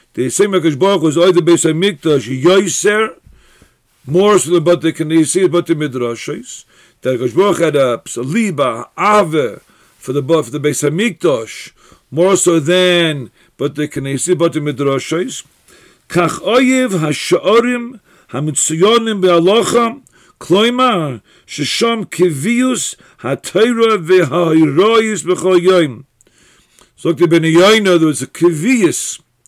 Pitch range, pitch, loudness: 150-200 Hz, 175 Hz, -13 LUFS